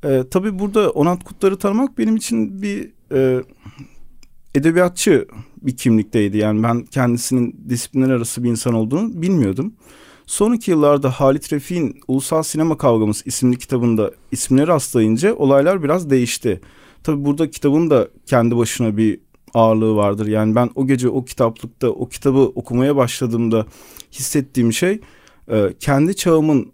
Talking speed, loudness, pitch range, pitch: 135 wpm, -17 LUFS, 115-155 Hz, 130 Hz